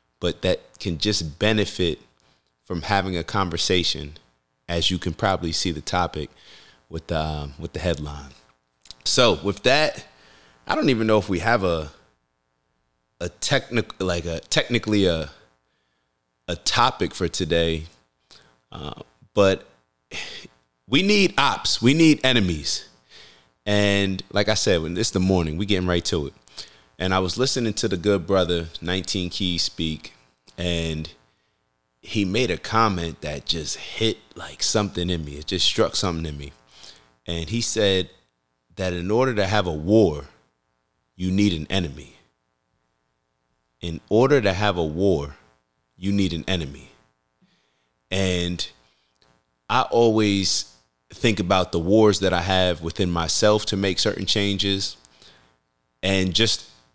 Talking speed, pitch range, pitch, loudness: 140 wpm, 60-95 Hz, 85 Hz, -22 LUFS